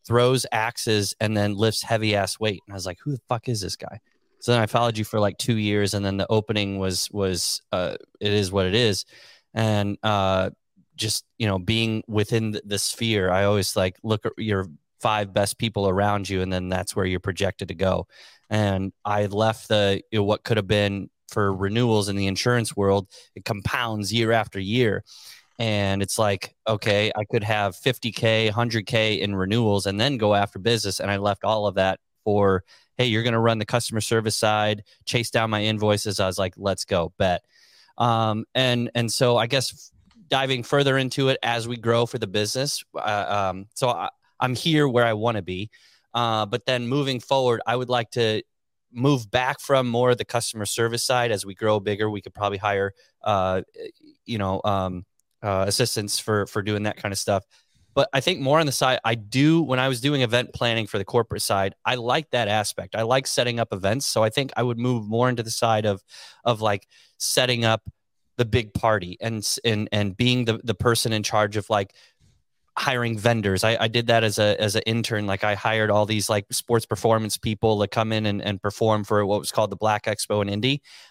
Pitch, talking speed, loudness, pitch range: 110 Hz, 215 wpm, -23 LUFS, 100-120 Hz